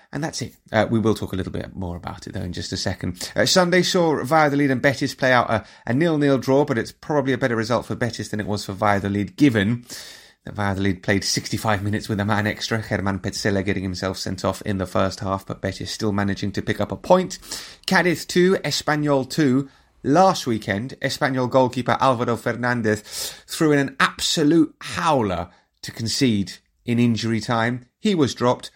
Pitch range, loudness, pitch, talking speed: 100-135 Hz, -21 LUFS, 115 Hz, 200 wpm